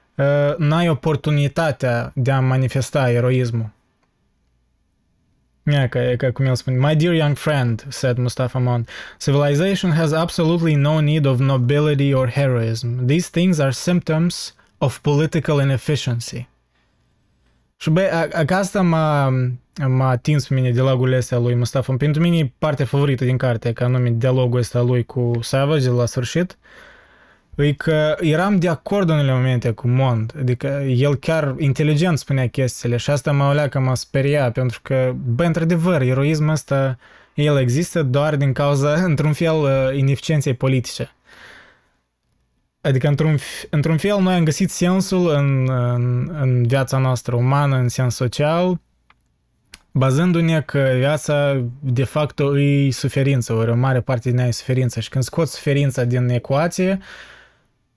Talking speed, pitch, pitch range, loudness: 145 wpm, 135 Hz, 125-155 Hz, -19 LUFS